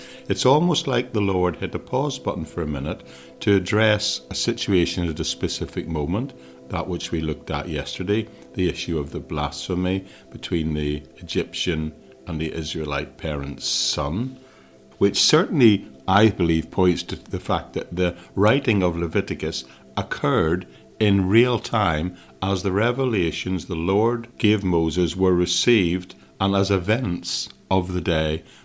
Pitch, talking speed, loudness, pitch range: 90 Hz, 150 wpm, -23 LUFS, 80-105 Hz